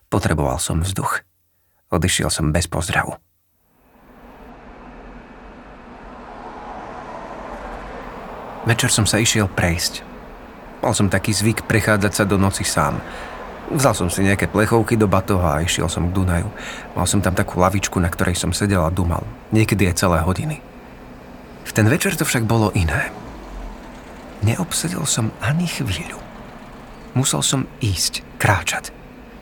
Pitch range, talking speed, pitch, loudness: 90-115 Hz, 130 wpm, 100 Hz, -19 LUFS